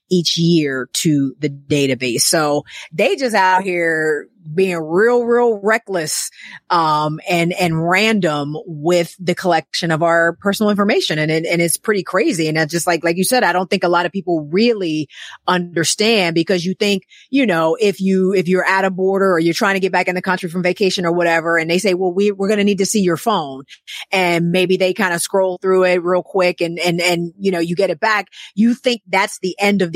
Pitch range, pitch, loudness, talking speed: 170-195 Hz, 180 Hz, -16 LUFS, 220 wpm